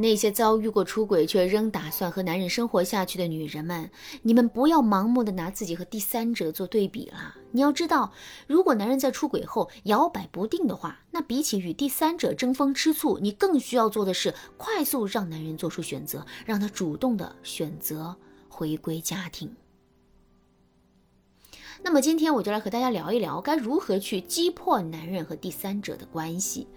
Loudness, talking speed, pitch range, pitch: -26 LUFS, 280 characters per minute, 180-265 Hz, 215 Hz